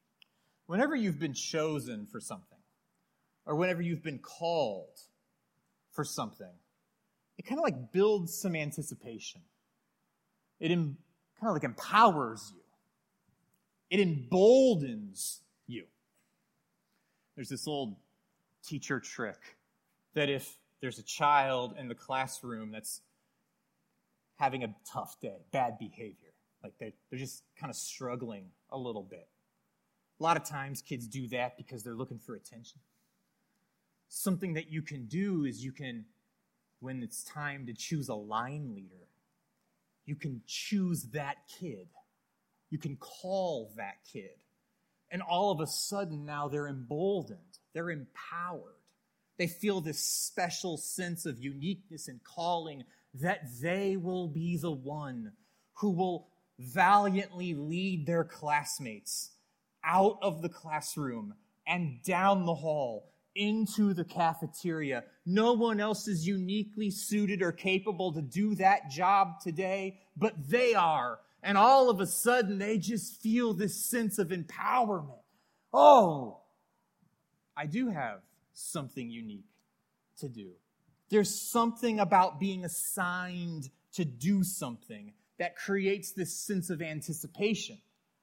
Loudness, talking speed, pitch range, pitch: -32 LUFS, 130 wpm, 150-205 Hz, 180 Hz